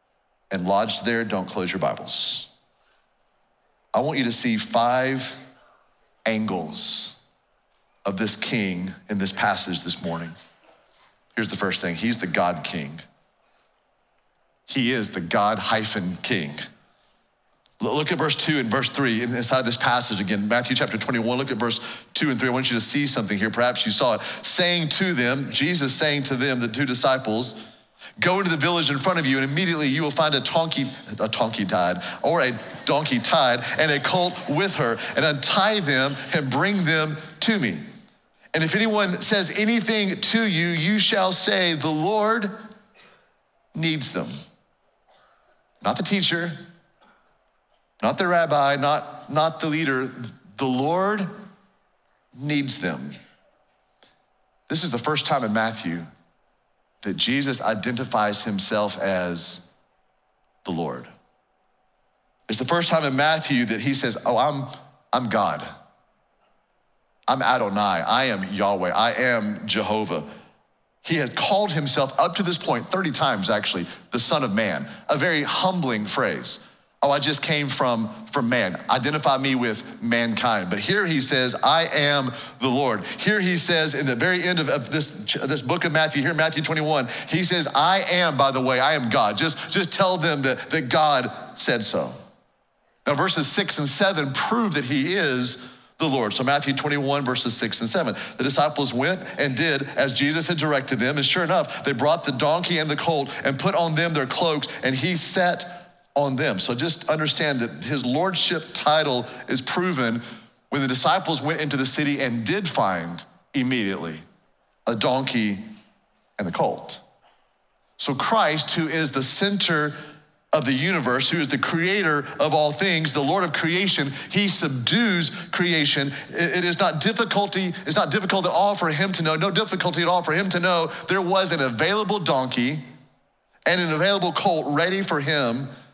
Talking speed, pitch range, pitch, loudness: 170 wpm, 130-175 Hz, 150 Hz, -20 LUFS